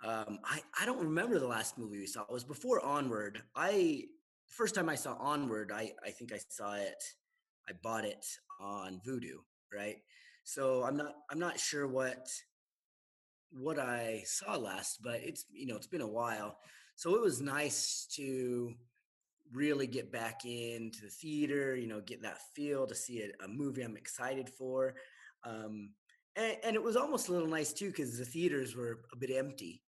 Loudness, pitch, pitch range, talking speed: -38 LUFS, 130 Hz, 115-145 Hz, 185 wpm